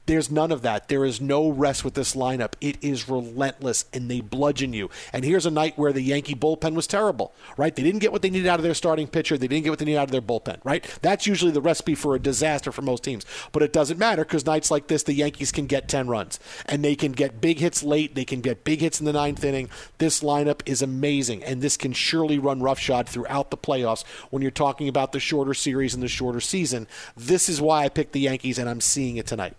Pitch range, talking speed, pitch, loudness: 130-155 Hz, 260 wpm, 145 Hz, -24 LUFS